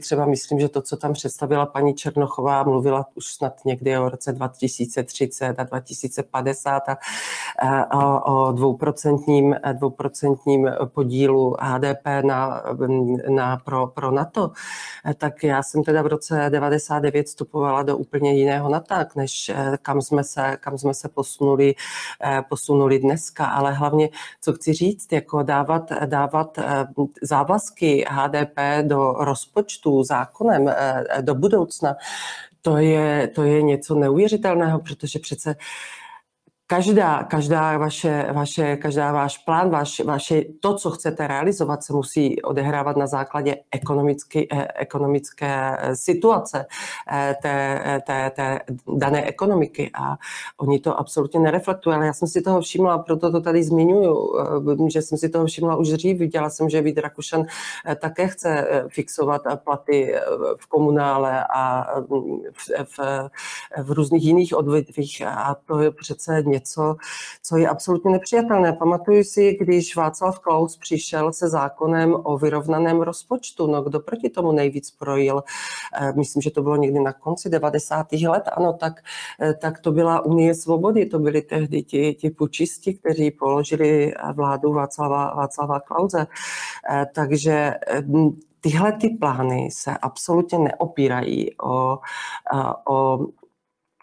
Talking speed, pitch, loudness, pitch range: 130 wpm, 150 Hz, -21 LUFS, 140-160 Hz